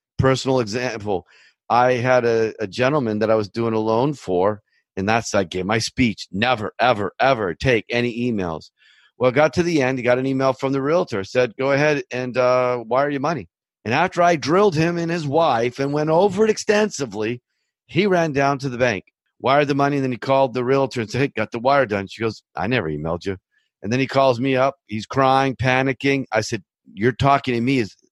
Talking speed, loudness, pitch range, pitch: 220 wpm, -20 LUFS, 115-140 Hz, 130 Hz